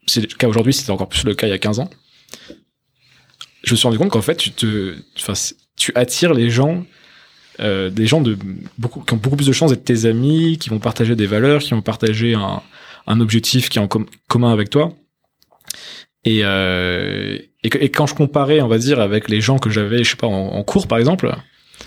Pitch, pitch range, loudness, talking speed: 115 Hz, 105-135 Hz, -17 LUFS, 230 wpm